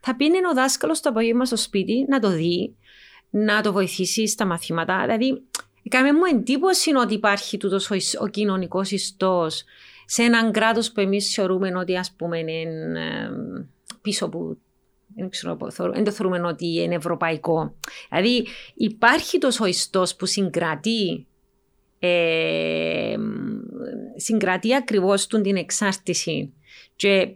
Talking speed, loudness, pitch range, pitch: 125 wpm, -22 LUFS, 180-235 Hz, 200 Hz